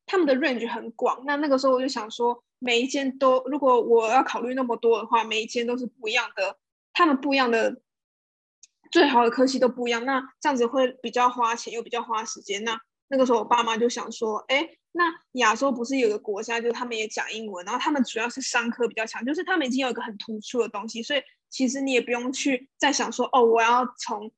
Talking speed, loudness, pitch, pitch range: 360 characters per minute, -24 LUFS, 245 Hz, 230-265 Hz